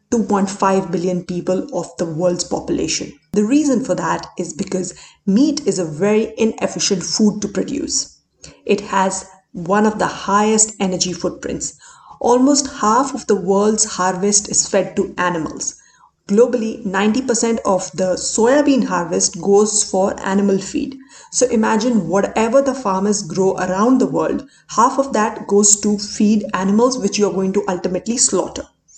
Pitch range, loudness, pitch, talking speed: 190-230 Hz, -17 LUFS, 205 Hz, 150 wpm